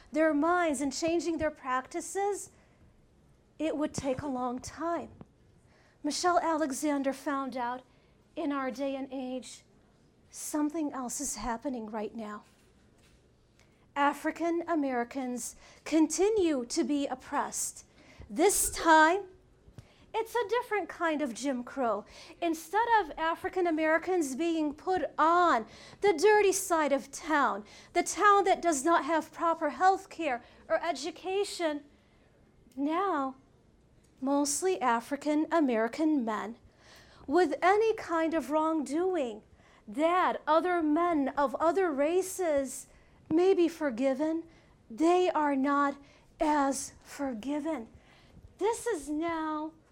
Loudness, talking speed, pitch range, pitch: -30 LUFS, 110 wpm, 280-340 Hz, 315 Hz